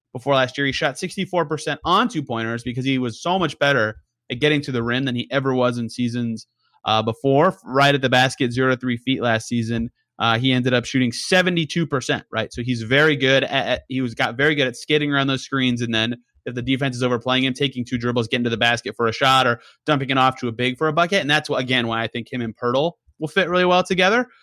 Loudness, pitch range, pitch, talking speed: -20 LUFS, 120-145 Hz, 130 Hz, 255 wpm